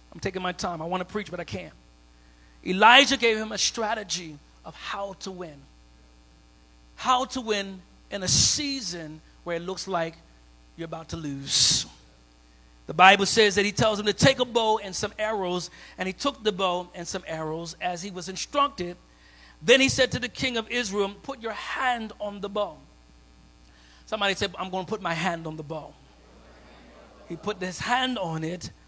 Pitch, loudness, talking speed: 180 Hz, -24 LUFS, 190 wpm